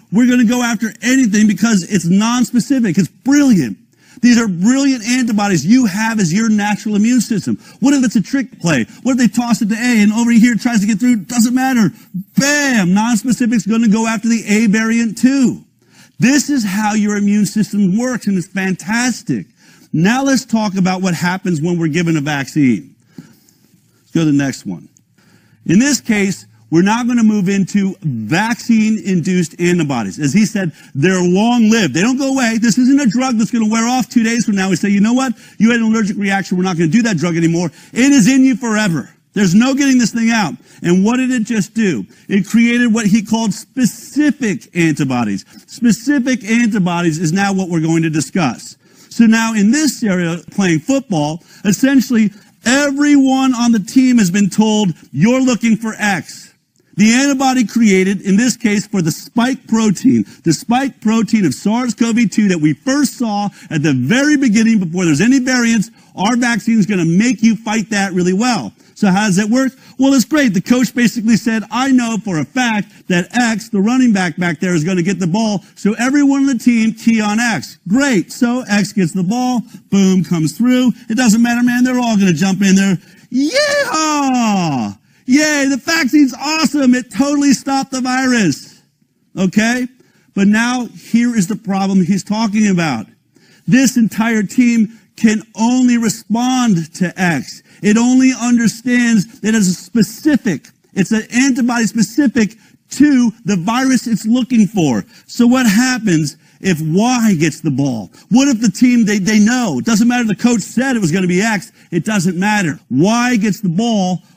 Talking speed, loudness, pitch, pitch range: 190 wpm, -14 LUFS, 220 Hz, 195-245 Hz